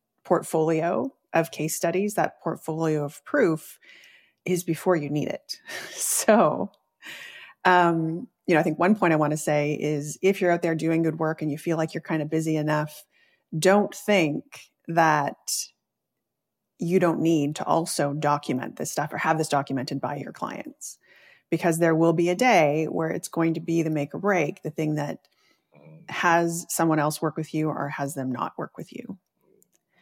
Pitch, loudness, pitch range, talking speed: 160 Hz, -25 LUFS, 150-175 Hz, 180 wpm